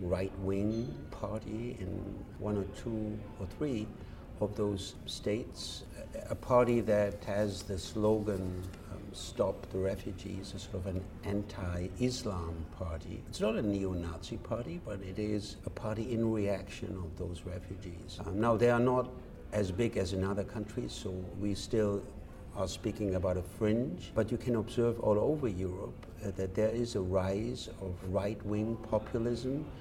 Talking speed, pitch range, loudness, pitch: 155 wpm, 95-110 Hz, -35 LUFS, 100 Hz